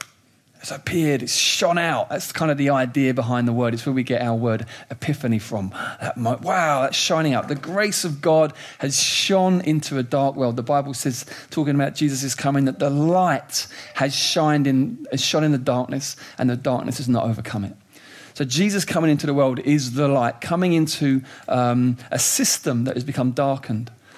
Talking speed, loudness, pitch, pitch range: 195 wpm, -21 LUFS, 140 Hz, 125-150 Hz